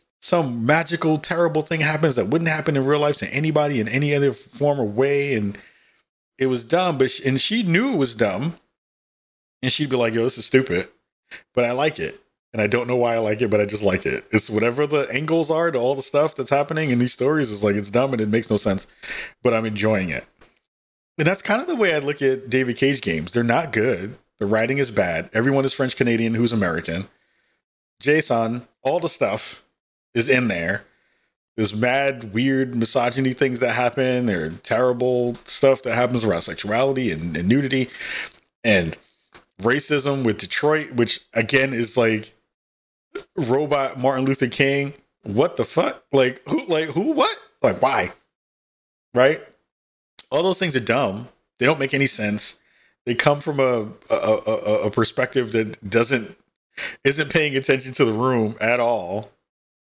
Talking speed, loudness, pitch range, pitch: 185 wpm, -21 LUFS, 115-145 Hz, 130 Hz